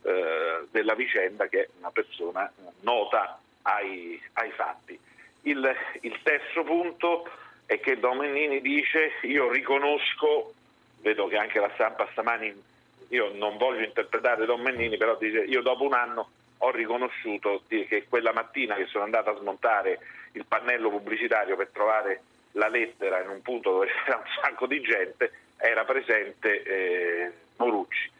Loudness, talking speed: -27 LUFS, 145 wpm